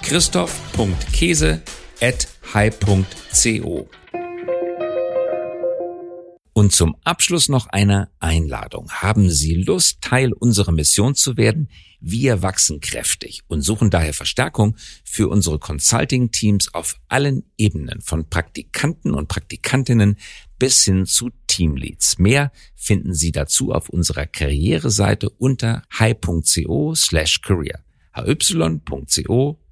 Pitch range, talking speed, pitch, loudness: 85-125 Hz, 100 wpm, 100 Hz, -18 LUFS